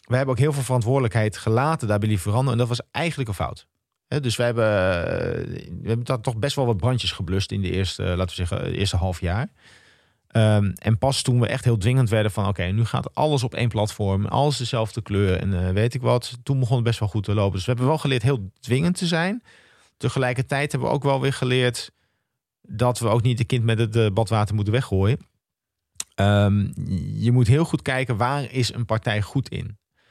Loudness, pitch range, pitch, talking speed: -23 LUFS, 105-130 Hz, 120 Hz, 215 wpm